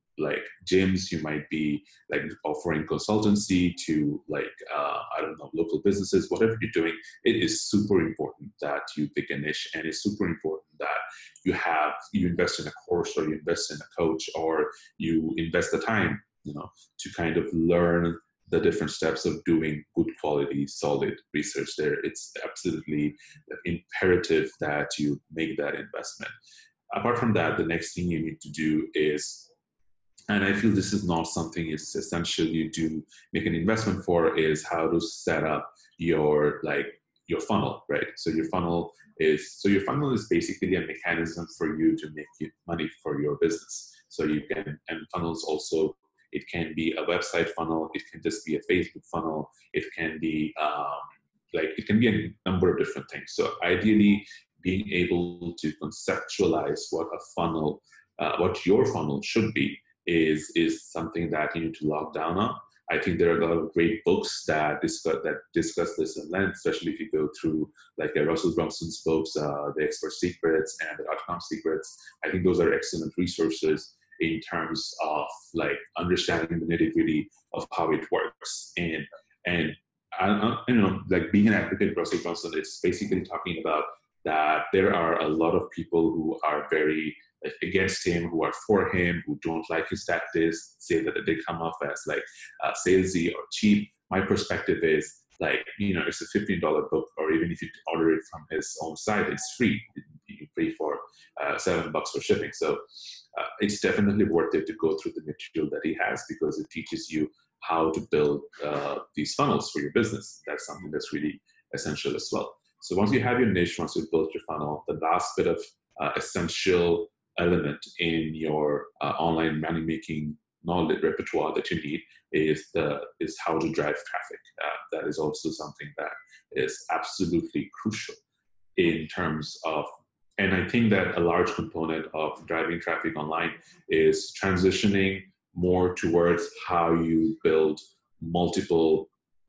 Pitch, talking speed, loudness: 90 Hz, 180 wpm, -28 LUFS